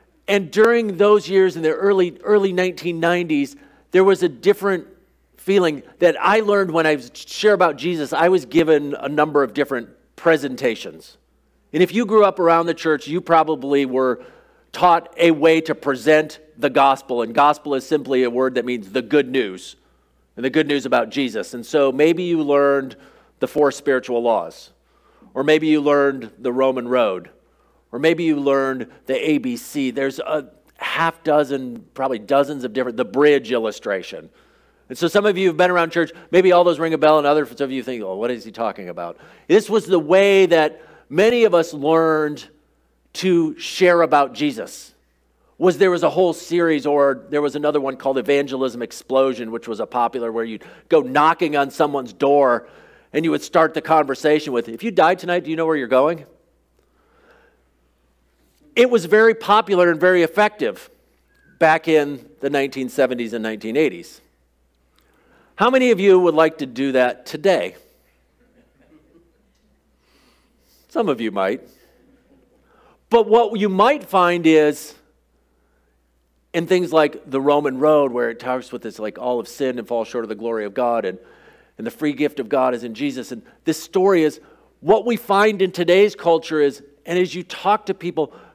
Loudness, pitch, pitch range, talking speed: -18 LUFS, 150 Hz, 130-175 Hz, 180 wpm